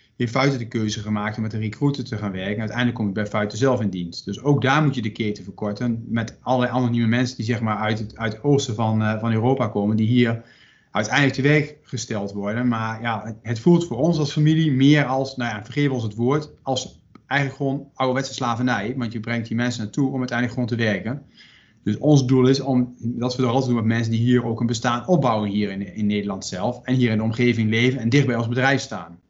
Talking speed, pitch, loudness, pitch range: 245 wpm, 120 Hz, -22 LUFS, 110-130 Hz